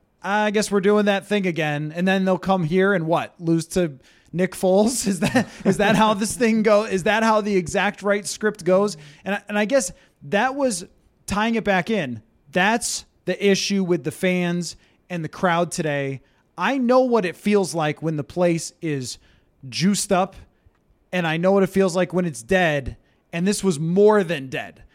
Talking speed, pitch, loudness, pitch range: 200 wpm, 185 Hz, -21 LUFS, 165-205 Hz